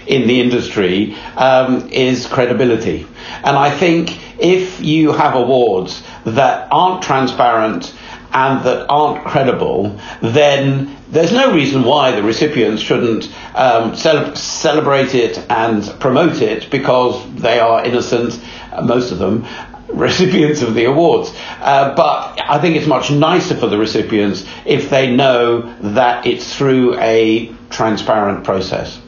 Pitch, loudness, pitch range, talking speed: 135 Hz, -14 LUFS, 120-150 Hz, 135 wpm